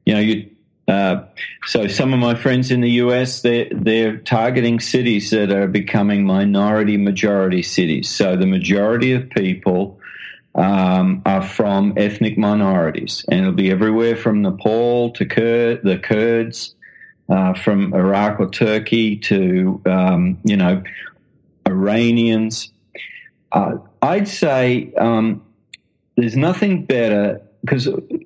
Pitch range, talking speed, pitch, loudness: 100-120 Hz, 125 wpm, 110 Hz, -17 LUFS